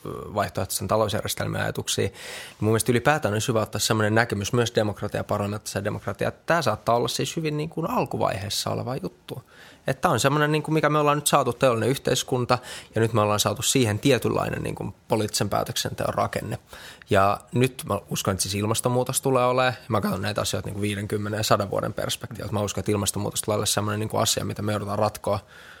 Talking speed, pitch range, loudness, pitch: 185 wpm, 105-130 Hz, -24 LUFS, 110 Hz